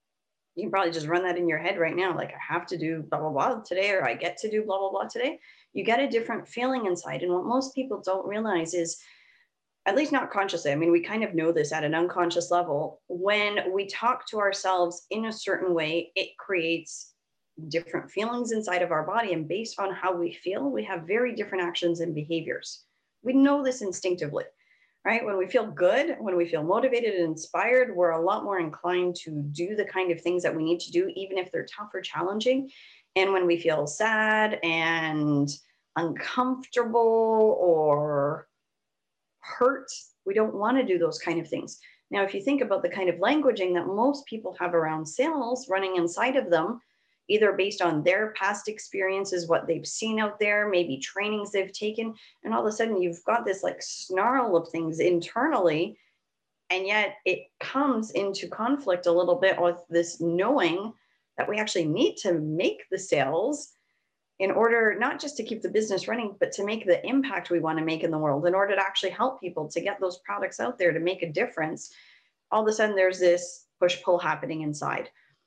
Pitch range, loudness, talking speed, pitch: 170-220 Hz, -27 LUFS, 205 wpm, 190 Hz